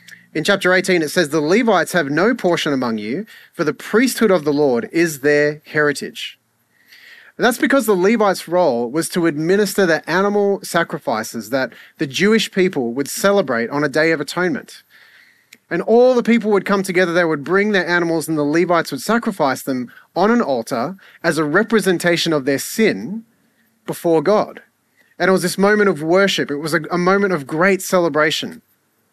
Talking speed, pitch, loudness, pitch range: 180 wpm, 180 Hz, -17 LUFS, 160-205 Hz